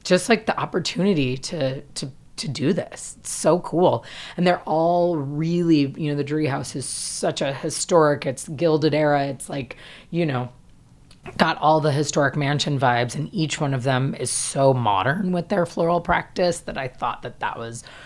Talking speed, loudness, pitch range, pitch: 185 wpm, -22 LUFS, 135-170 Hz, 150 Hz